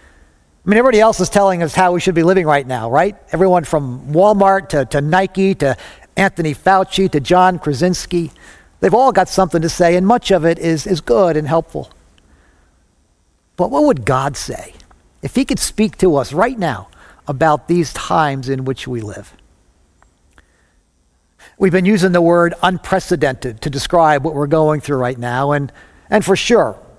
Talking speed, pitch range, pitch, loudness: 180 wpm, 125-185 Hz, 160 Hz, -15 LUFS